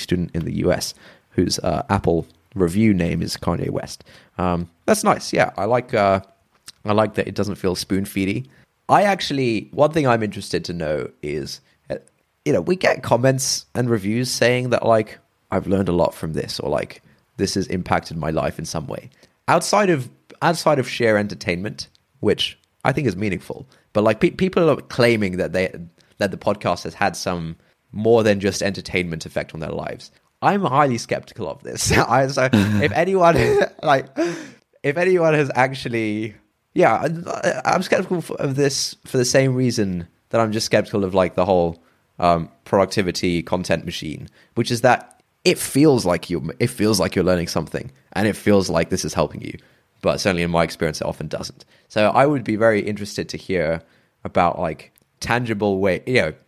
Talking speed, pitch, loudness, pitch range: 185 wpm, 105 Hz, -20 LUFS, 90-130 Hz